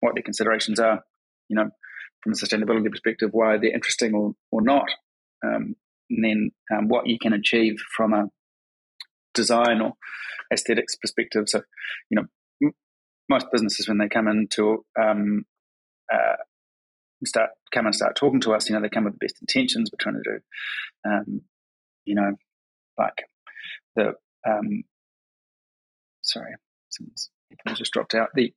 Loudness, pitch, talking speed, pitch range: -24 LUFS, 110 Hz, 150 wpm, 105-115 Hz